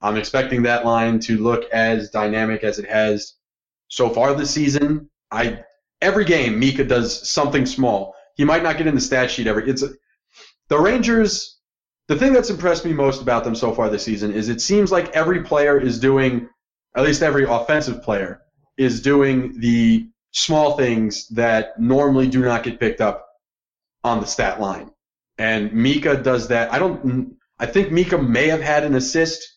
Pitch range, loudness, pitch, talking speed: 115-155 Hz, -19 LUFS, 130 Hz, 185 wpm